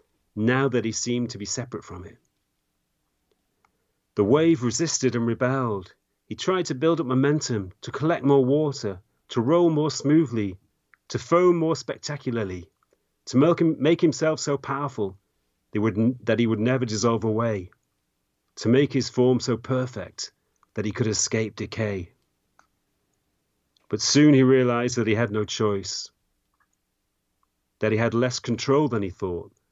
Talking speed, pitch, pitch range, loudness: 145 wpm, 120 Hz, 110-140 Hz, -24 LUFS